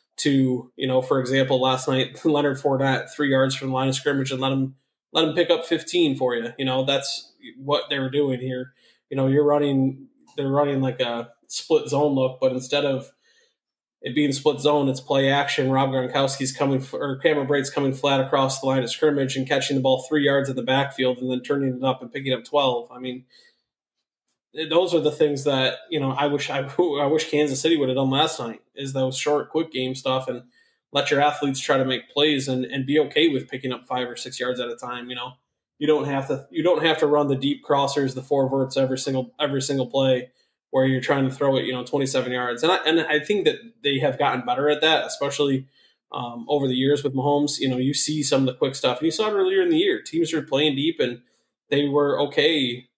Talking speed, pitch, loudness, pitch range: 240 wpm, 135 Hz, -22 LUFS, 130-145 Hz